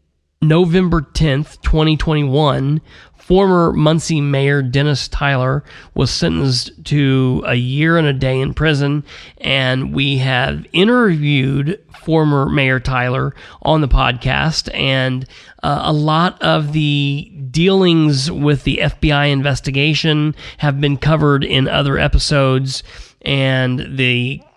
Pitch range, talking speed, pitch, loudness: 130-155 Hz, 115 wpm, 140 Hz, -15 LUFS